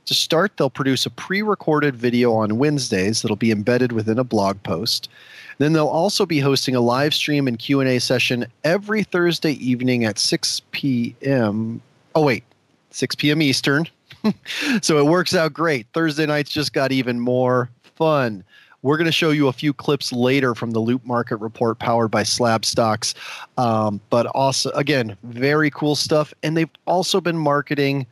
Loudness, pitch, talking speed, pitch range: -20 LUFS, 135 Hz, 170 wpm, 120-155 Hz